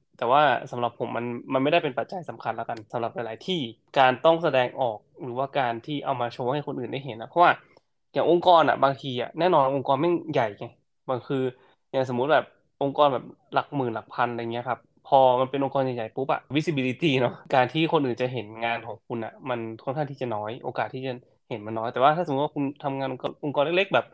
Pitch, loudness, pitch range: 130 Hz, -25 LUFS, 120-140 Hz